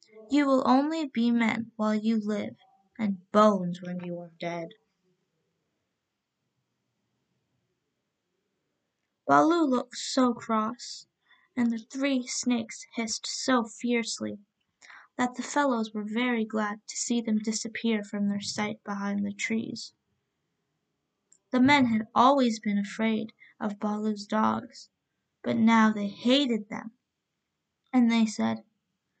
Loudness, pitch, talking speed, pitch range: -27 LUFS, 225 Hz, 120 wpm, 205-245 Hz